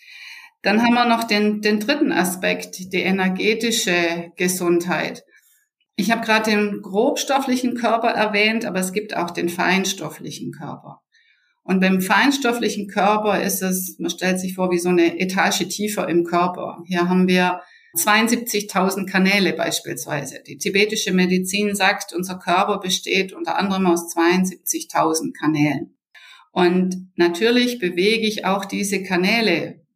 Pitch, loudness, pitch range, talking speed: 190 Hz, -19 LUFS, 180-215 Hz, 135 wpm